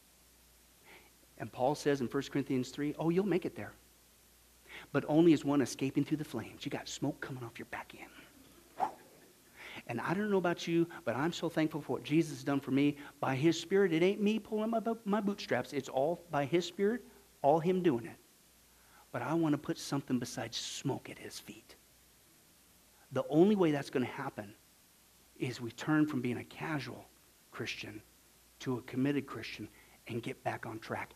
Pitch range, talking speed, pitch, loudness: 130-170 Hz, 190 wpm, 145 Hz, -34 LUFS